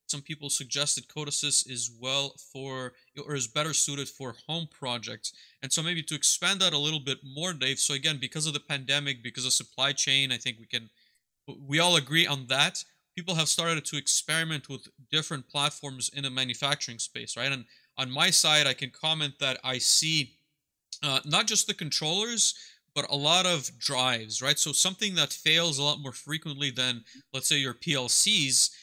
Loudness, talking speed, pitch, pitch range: -26 LUFS, 190 wpm, 145 Hz, 130-155 Hz